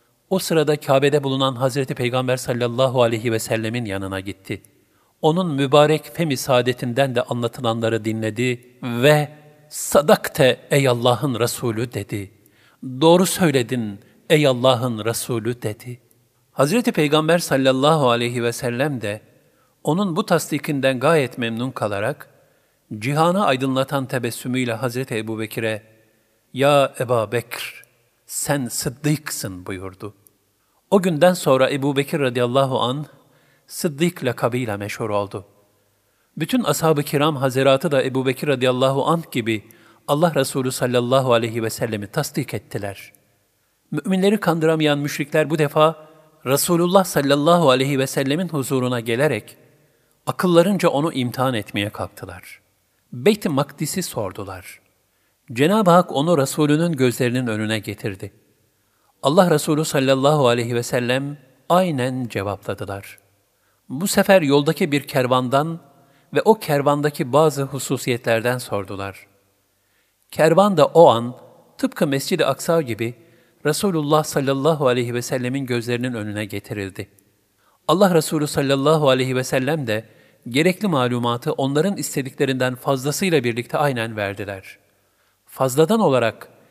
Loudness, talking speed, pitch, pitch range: -20 LUFS, 115 wpm, 130 Hz, 115-150 Hz